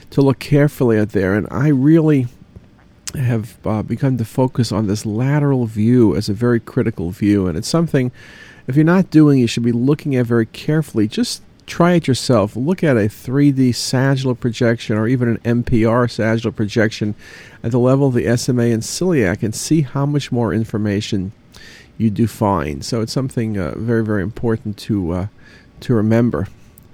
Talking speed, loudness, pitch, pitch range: 180 wpm, -17 LUFS, 115 Hz, 110-130 Hz